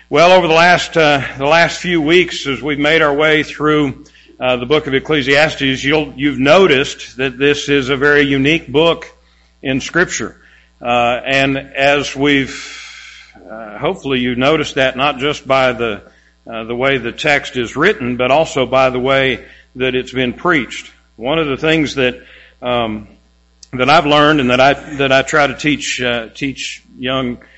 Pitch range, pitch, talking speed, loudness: 125-150 Hz, 135 Hz, 175 wpm, -14 LUFS